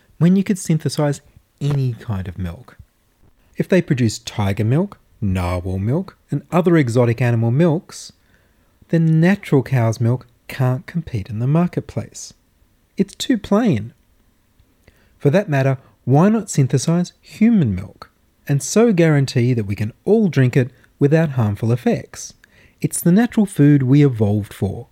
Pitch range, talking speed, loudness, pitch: 110-165 Hz, 140 wpm, -18 LUFS, 130 Hz